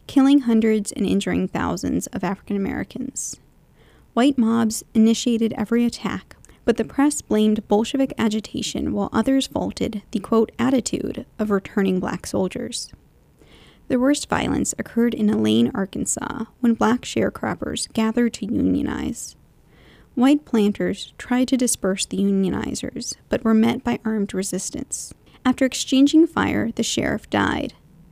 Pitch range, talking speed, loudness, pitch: 205-255 Hz, 130 wpm, -21 LUFS, 225 Hz